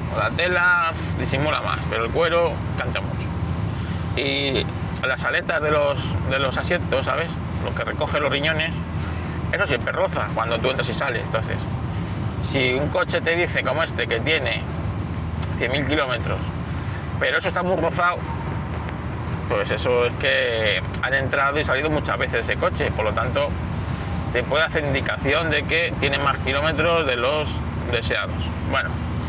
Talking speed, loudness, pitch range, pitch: 160 wpm, -22 LUFS, 90-145 Hz, 115 Hz